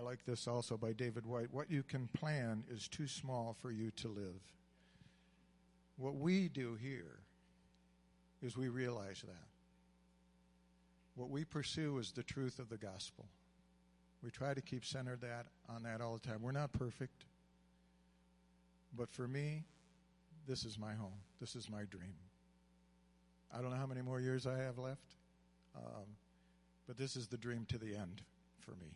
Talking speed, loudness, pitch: 170 wpm, -45 LUFS, 115 Hz